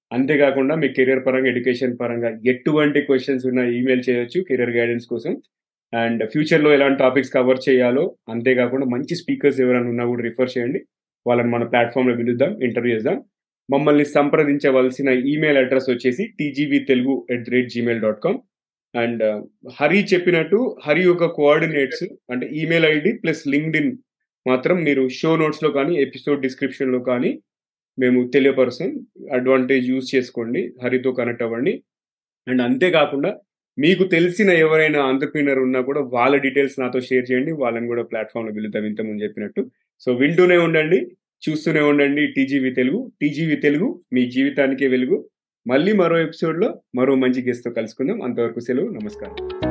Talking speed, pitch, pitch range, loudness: 140 wpm, 130 Hz, 125-150 Hz, -19 LUFS